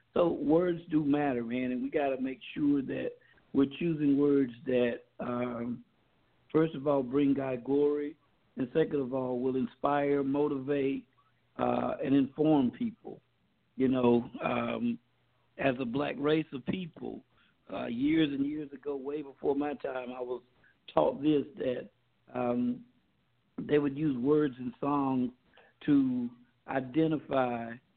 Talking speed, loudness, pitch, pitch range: 140 wpm, -31 LUFS, 140 Hz, 125-150 Hz